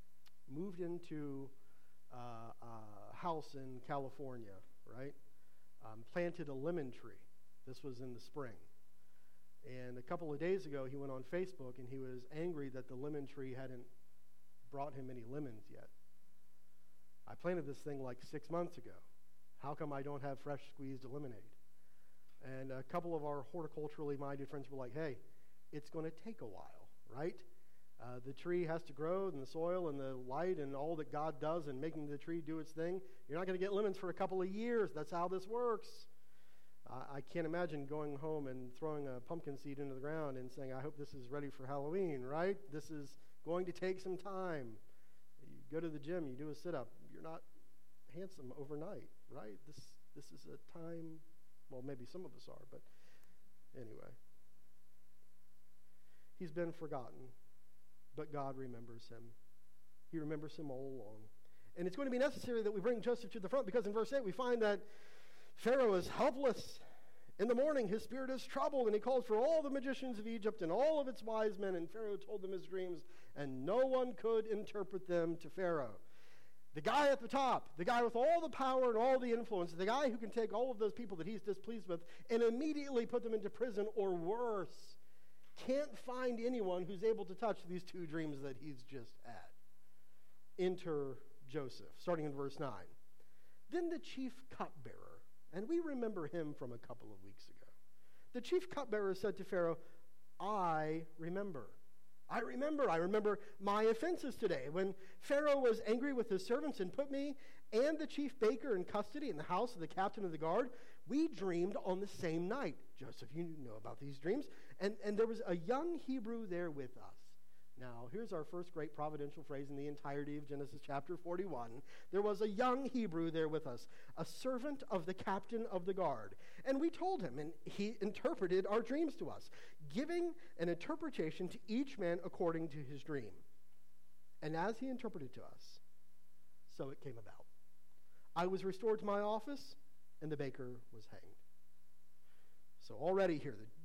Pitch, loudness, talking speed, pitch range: 160 Hz, -42 LUFS, 190 wpm, 130-205 Hz